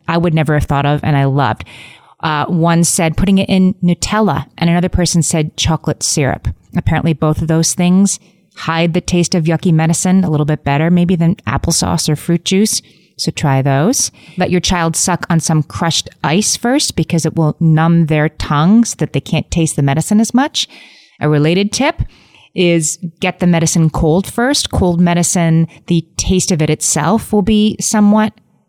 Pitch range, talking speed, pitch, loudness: 155-185 Hz, 185 wpm, 170 Hz, -13 LUFS